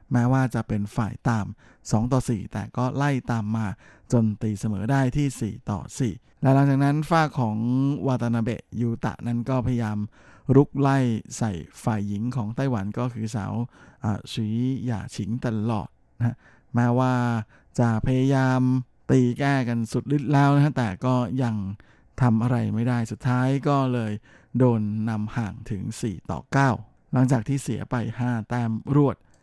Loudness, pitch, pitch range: -25 LUFS, 120 Hz, 110-130 Hz